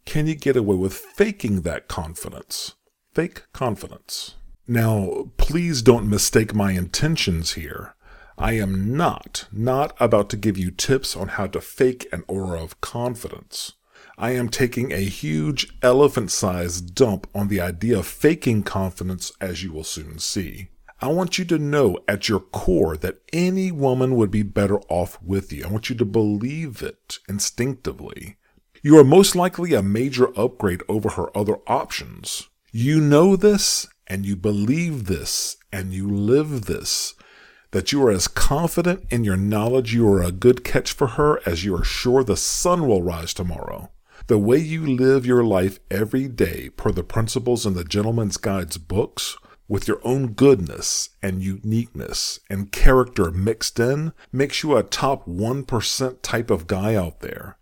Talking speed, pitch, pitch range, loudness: 165 wpm, 110 Hz, 95-130 Hz, -21 LUFS